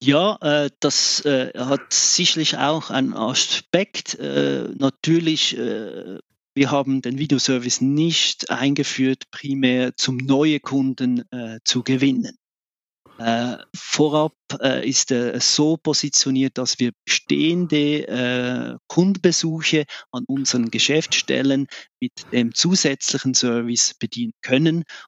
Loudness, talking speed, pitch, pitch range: -20 LUFS, 90 wpm, 135 Hz, 125-155 Hz